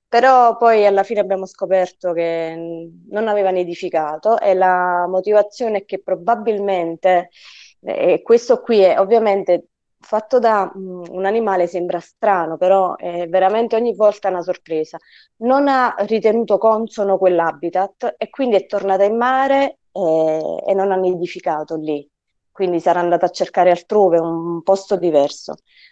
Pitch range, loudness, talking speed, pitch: 175-220 Hz, -17 LUFS, 140 wpm, 190 Hz